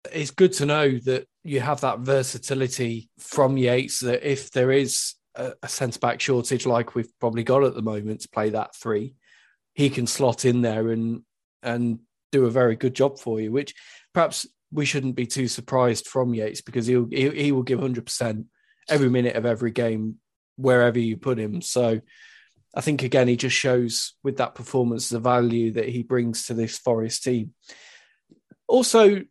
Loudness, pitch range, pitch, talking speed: -23 LUFS, 115-135 Hz, 125 Hz, 185 wpm